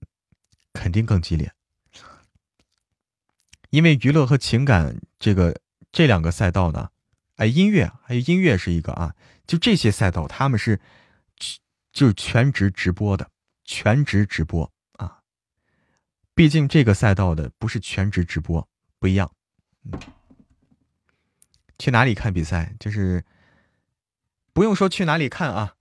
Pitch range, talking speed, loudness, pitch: 90-135 Hz, 200 characters per minute, -21 LUFS, 105 Hz